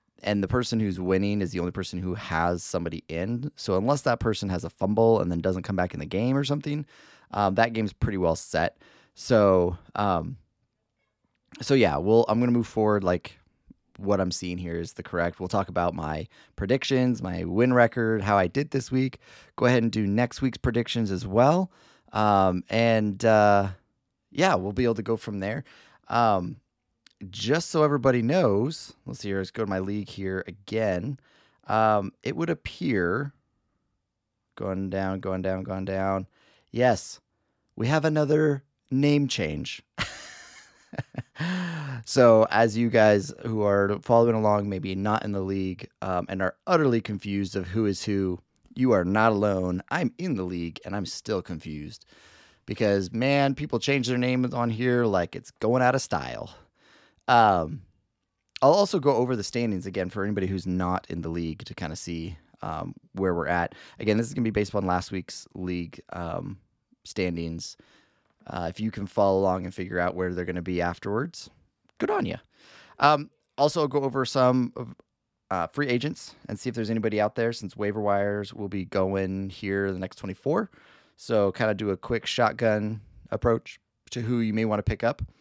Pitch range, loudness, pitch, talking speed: 95-120 Hz, -26 LUFS, 105 Hz, 185 wpm